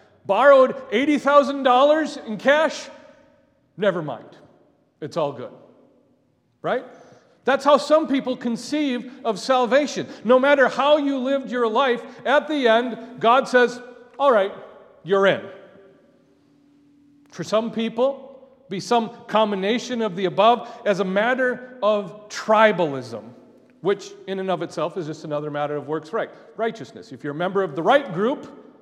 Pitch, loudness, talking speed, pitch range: 245 Hz, -21 LUFS, 140 wpm, 205-275 Hz